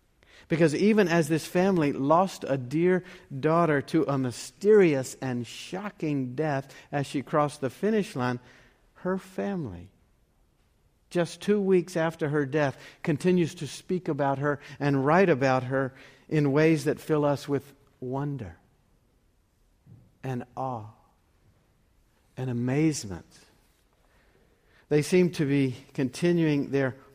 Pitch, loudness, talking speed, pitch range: 145 Hz, -27 LUFS, 120 wpm, 130-165 Hz